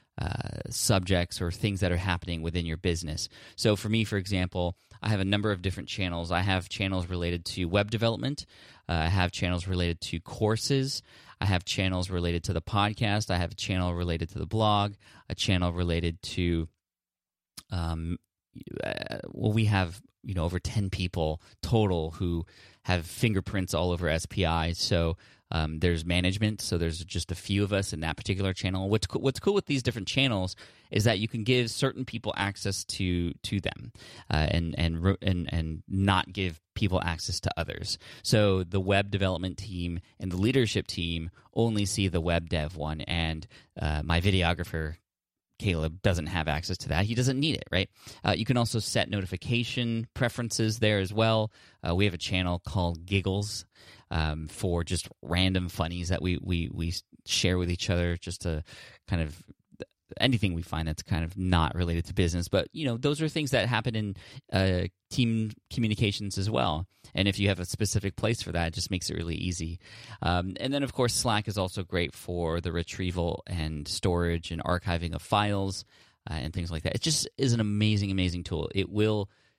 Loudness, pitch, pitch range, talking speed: -29 LUFS, 95 Hz, 85-105 Hz, 195 wpm